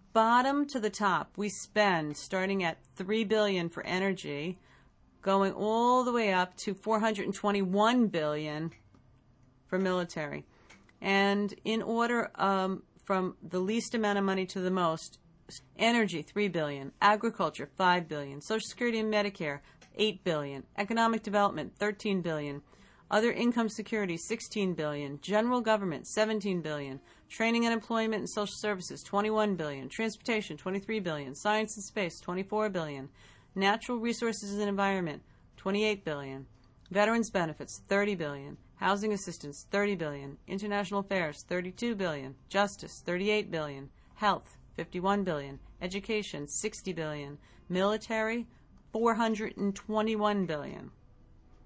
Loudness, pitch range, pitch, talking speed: -31 LUFS, 160-215 Hz, 195 Hz, 130 wpm